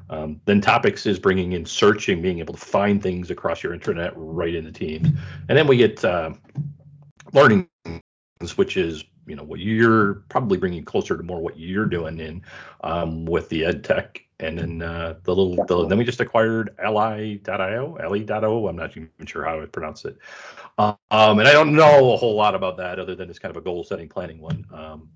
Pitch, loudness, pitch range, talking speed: 100 Hz, -20 LUFS, 85-115 Hz, 210 wpm